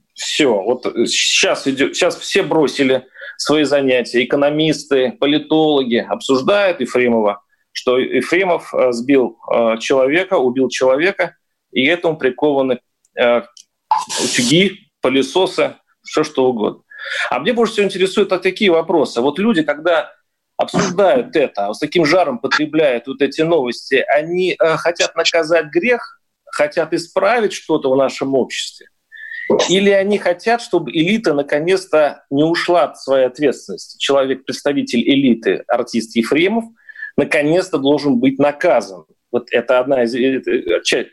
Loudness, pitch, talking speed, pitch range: -16 LUFS, 155 Hz, 120 wpm, 130-190 Hz